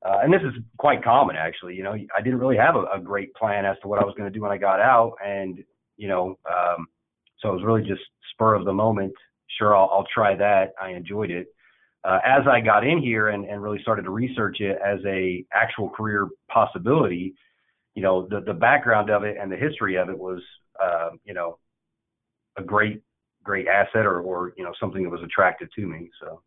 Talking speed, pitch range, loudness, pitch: 225 wpm, 95-105 Hz, -23 LUFS, 100 Hz